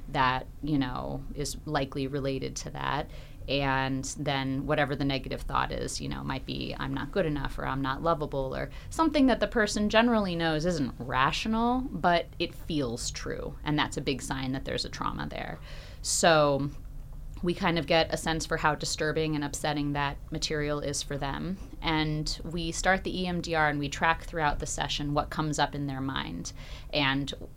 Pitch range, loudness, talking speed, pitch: 140-165 Hz, -29 LUFS, 185 wpm, 150 Hz